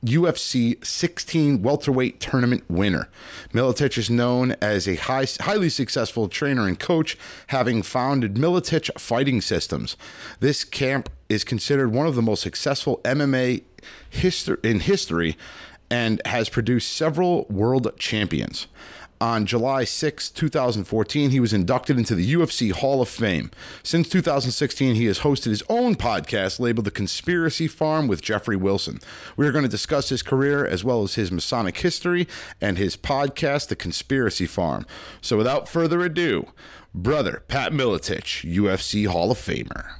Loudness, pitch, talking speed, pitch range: -23 LUFS, 125 Hz, 145 wpm, 105-145 Hz